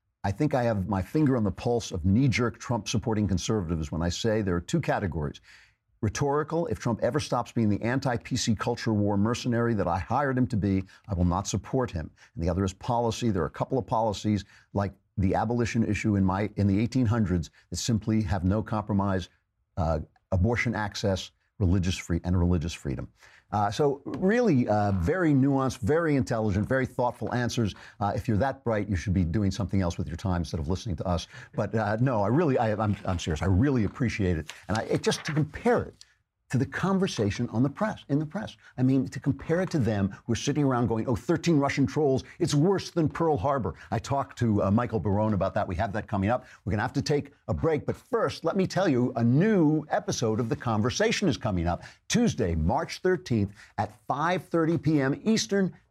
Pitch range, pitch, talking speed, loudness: 100-135 Hz, 110 Hz, 210 wpm, -27 LUFS